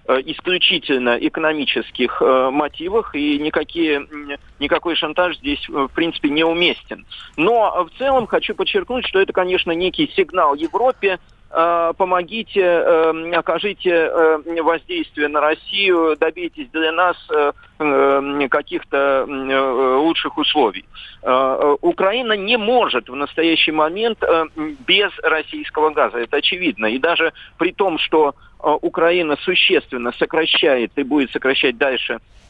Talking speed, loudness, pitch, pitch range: 105 wpm, -17 LUFS, 165 Hz, 150-190 Hz